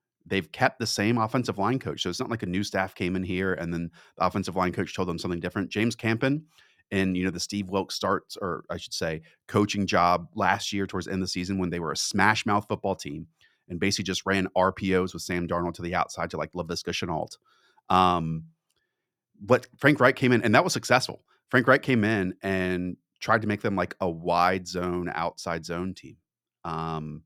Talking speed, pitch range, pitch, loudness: 220 wpm, 90-105 Hz, 95 Hz, -27 LUFS